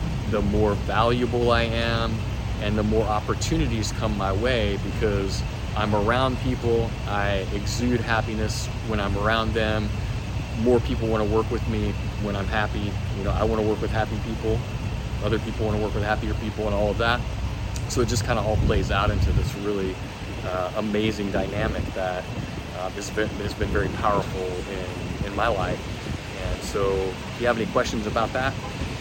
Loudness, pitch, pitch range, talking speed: -25 LUFS, 105 Hz, 100-115 Hz, 185 wpm